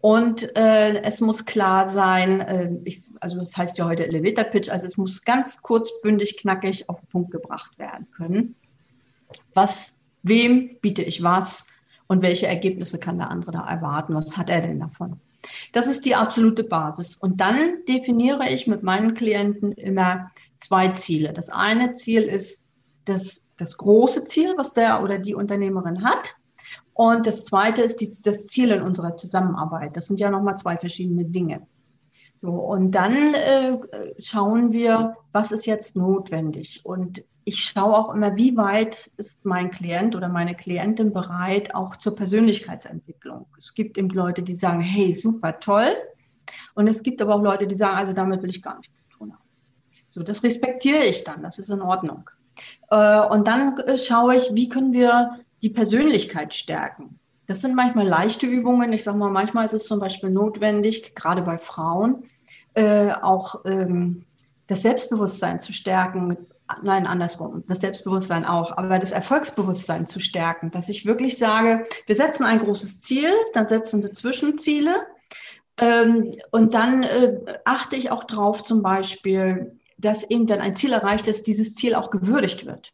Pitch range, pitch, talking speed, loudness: 180-225 Hz, 200 Hz, 170 wpm, -21 LUFS